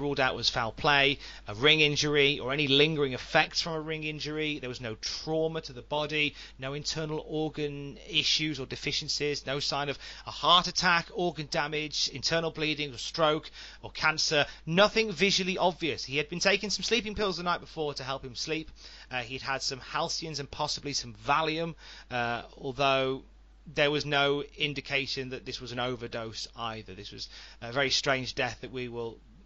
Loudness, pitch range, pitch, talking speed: -29 LUFS, 130-155 Hz, 145 Hz, 185 wpm